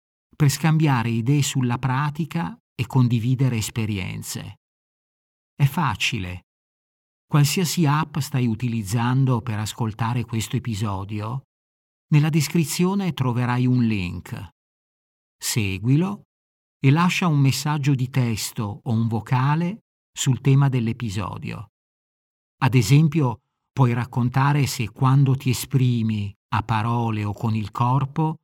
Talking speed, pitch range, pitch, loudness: 105 wpm, 110-145 Hz, 125 Hz, -22 LUFS